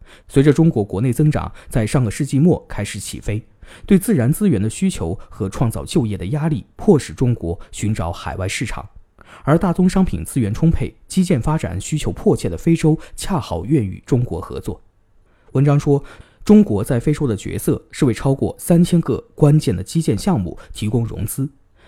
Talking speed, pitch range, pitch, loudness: 275 characters per minute, 105-155 Hz, 130 Hz, -18 LUFS